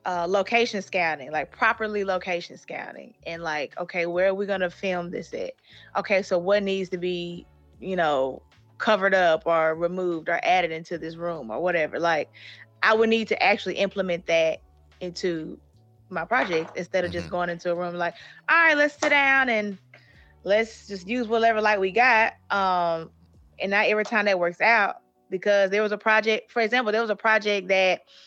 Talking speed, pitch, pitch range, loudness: 185 wpm, 185 Hz, 165-215 Hz, -24 LUFS